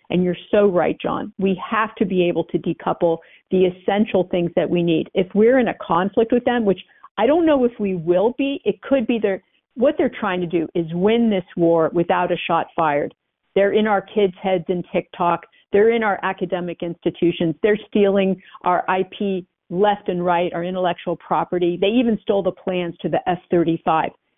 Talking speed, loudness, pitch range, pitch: 195 wpm, -20 LUFS, 175-210 Hz, 185 Hz